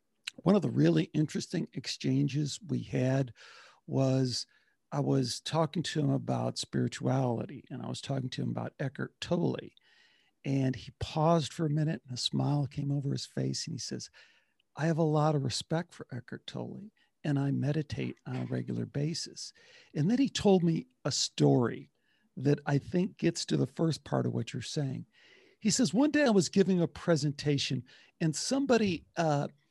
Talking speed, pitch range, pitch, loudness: 180 wpm, 130-165 Hz, 145 Hz, -31 LUFS